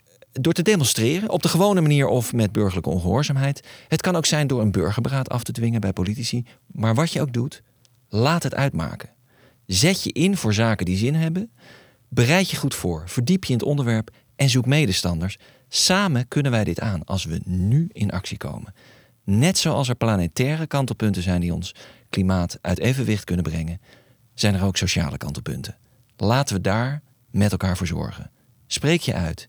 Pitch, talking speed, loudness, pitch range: 120 Hz, 185 wpm, -22 LUFS, 100-140 Hz